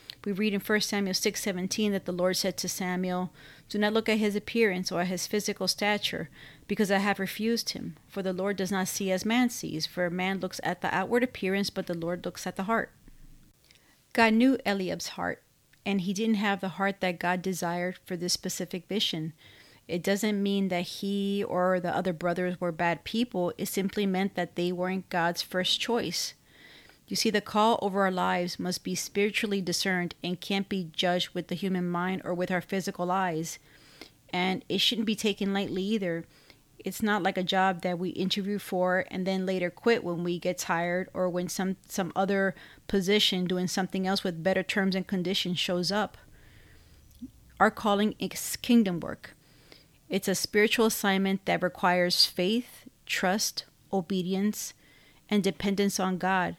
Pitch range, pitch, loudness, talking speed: 180-200 Hz, 190 Hz, -29 LUFS, 180 wpm